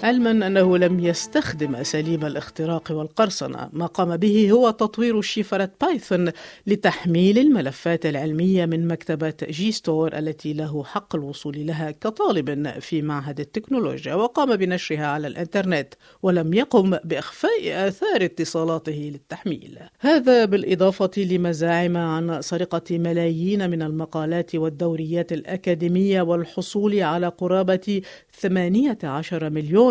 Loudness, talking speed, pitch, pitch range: -22 LUFS, 110 wpm, 175 Hz, 160-200 Hz